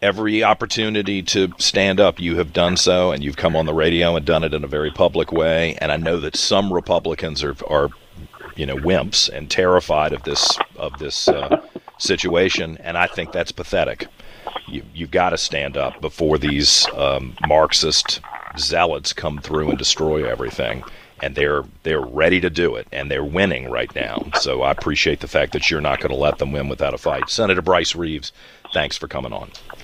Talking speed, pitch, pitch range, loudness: 195 wpm, 80 Hz, 75-90 Hz, -19 LUFS